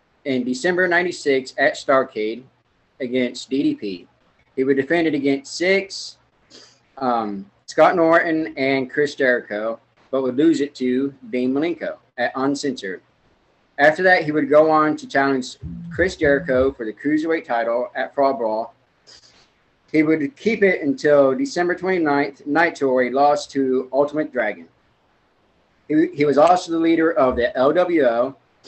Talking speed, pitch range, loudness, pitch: 140 wpm, 130-160 Hz, -19 LUFS, 140 Hz